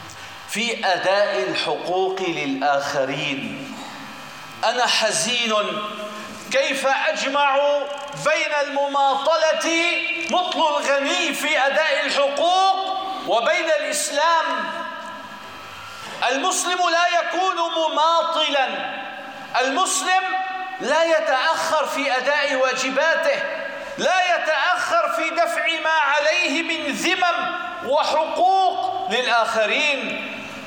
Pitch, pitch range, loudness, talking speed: 305 Hz, 270-330 Hz, -20 LUFS, 70 wpm